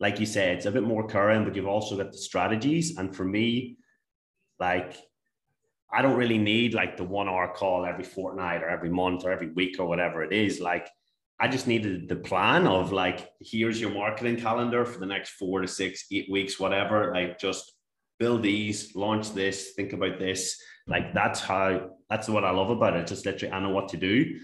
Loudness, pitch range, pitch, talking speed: -27 LUFS, 95-110 Hz, 95 Hz, 210 wpm